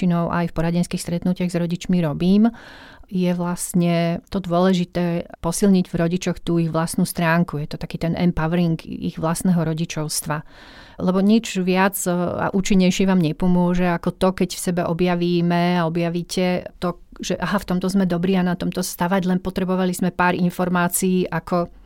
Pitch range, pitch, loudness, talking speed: 170-185 Hz, 175 Hz, -21 LUFS, 160 wpm